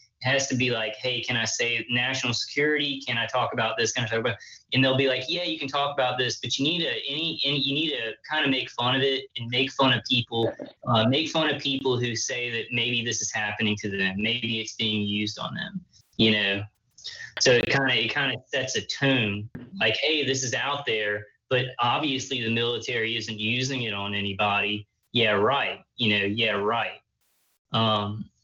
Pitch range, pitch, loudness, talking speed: 110-135 Hz, 120 Hz, -25 LUFS, 215 wpm